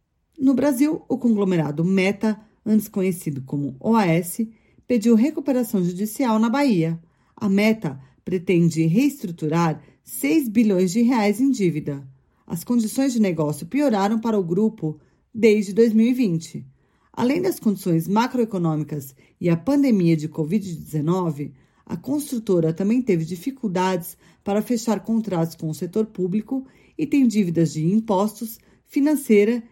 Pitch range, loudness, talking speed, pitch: 170-235 Hz, -21 LUFS, 125 wpm, 205 Hz